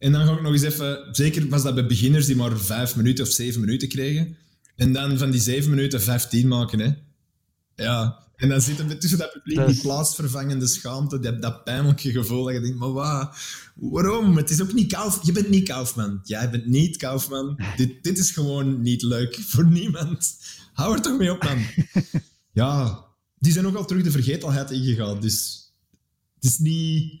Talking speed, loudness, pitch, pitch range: 205 wpm, -22 LUFS, 135 Hz, 120-155 Hz